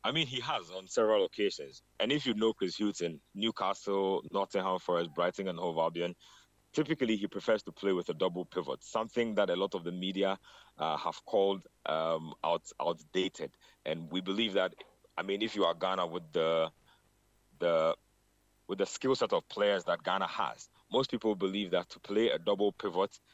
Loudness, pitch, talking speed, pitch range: -33 LUFS, 100 Hz, 190 wpm, 90-120 Hz